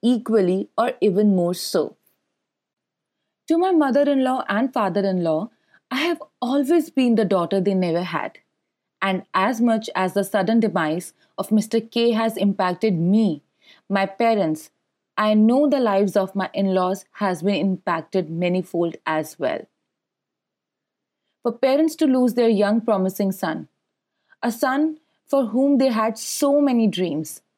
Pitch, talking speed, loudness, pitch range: 210 Hz, 140 wpm, -21 LUFS, 190-250 Hz